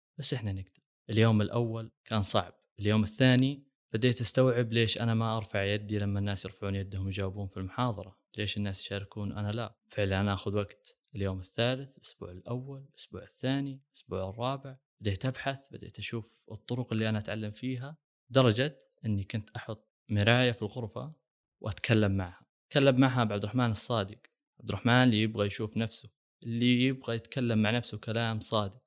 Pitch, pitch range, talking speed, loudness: 115 Hz, 105-125 Hz, 160 wpm, -31 LUFS